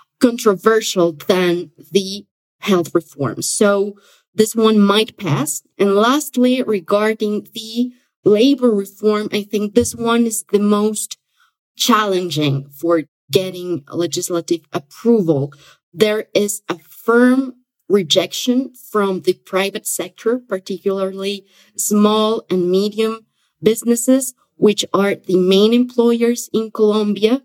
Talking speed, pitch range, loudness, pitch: 105 wpm, 185-225 Hz, -17 LUFS, 205 Hz